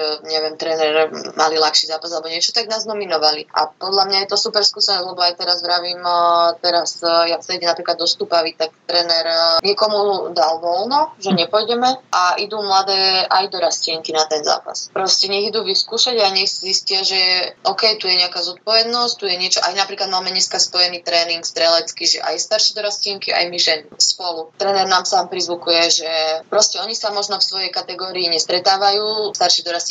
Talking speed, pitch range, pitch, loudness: 180 wpm, 170-200 Hz, 180 Hz, -16 LUFS